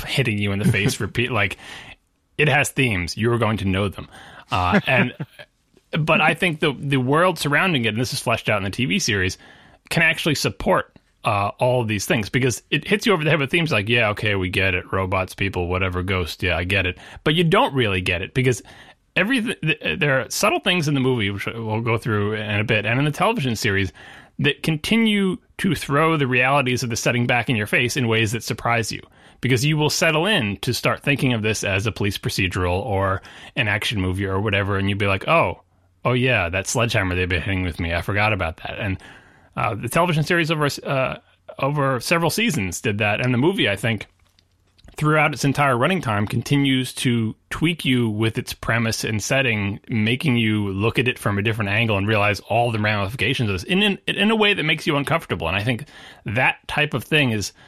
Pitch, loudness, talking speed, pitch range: 115 Hz, -20 LUFS, 220 wpm, 100-145 Hz